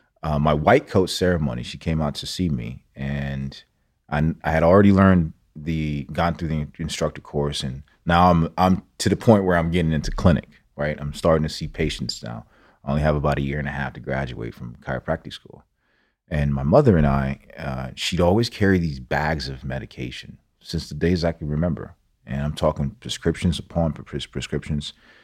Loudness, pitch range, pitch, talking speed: -22 LUFS, 70-85 Hz, 75 Hz, 195 wpm